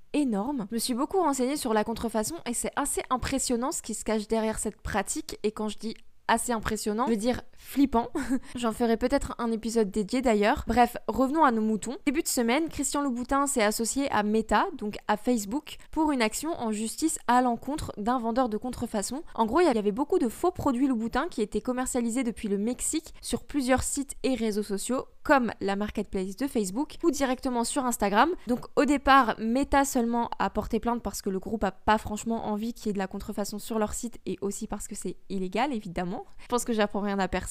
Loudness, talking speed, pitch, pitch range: -28 LUFS, 215 wpm, 235 Hz, 215-270 Hz